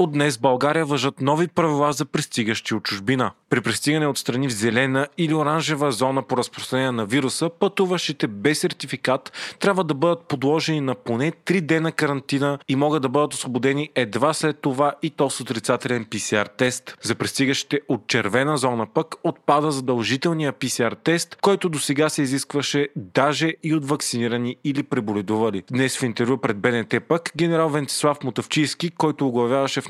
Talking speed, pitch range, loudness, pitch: 160 wpm, 130-155 Hz, -22 LUFS, 145 Hz